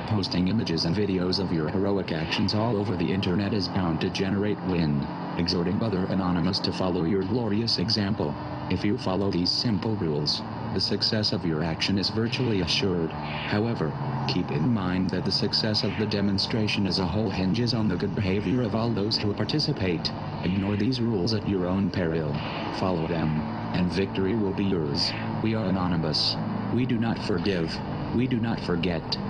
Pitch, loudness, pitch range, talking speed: 100 Hz, -26 LUFS, 90-110 Hz, 180 wpm